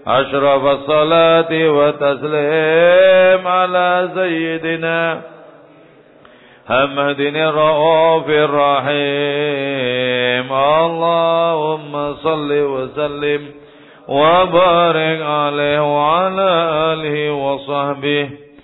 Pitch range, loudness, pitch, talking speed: 145-165 Hz, -14 LUFS, 150 Hz, 50 wpm